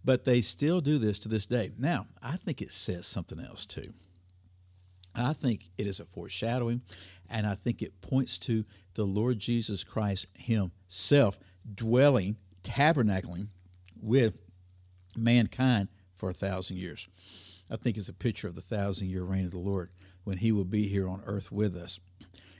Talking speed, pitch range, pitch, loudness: 165 wpm, 90-115 Hz, 100 Hz, -31 LUFS